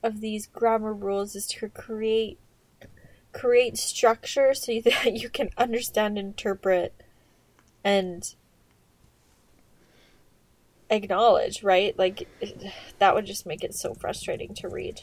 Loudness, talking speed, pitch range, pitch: -26 LUFS, 115 wpm, 200-240 Hz, 220 Hz